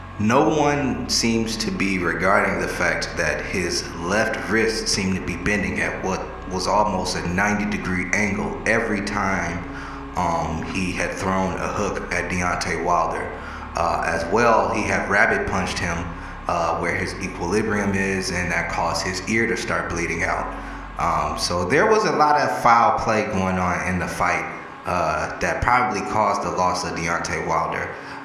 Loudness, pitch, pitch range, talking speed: -22 LUFS, 90 Hz, 85-105 Hz, 170 wpm